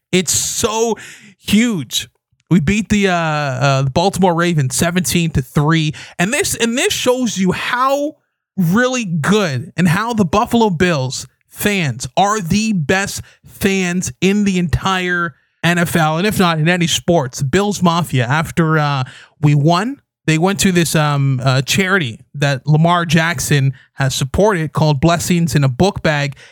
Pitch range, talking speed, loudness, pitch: 145-195 Hz, 155 wpm, -15 LUFS, 170 Hz